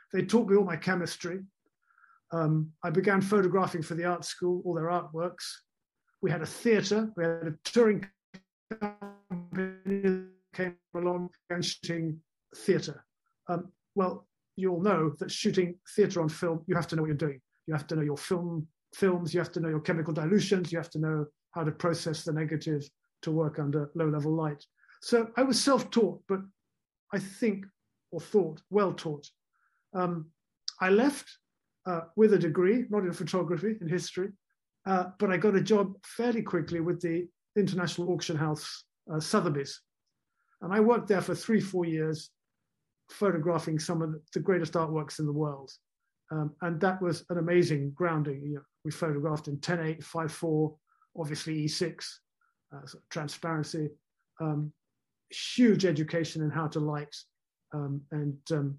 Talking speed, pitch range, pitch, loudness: 165 wpm, 155-190 Hz, 175 Hz, -30 LUFS